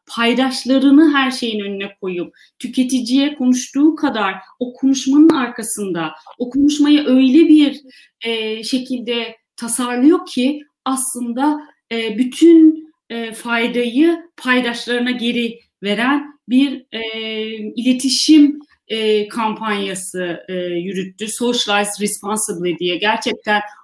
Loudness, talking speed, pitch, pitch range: -16 LUFS, 95 wpm, 245 Hz, 215-270 Hz